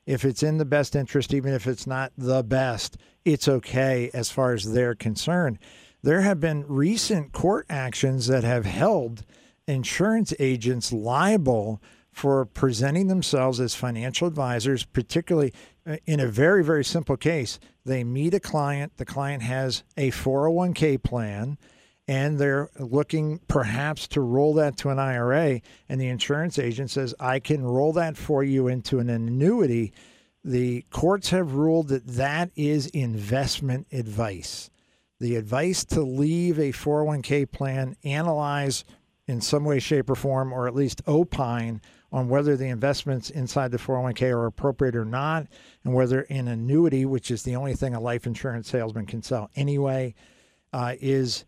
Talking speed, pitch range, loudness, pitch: 155 wpm, 125-150 Hz, -25 LUFS, 135 Hz